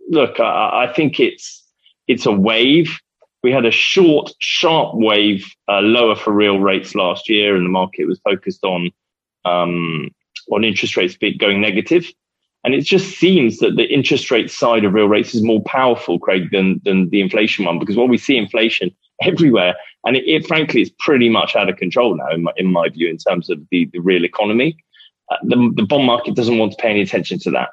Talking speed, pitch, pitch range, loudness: 210 wpm, 105 Hz, 95-120 Hz, -15 LUFS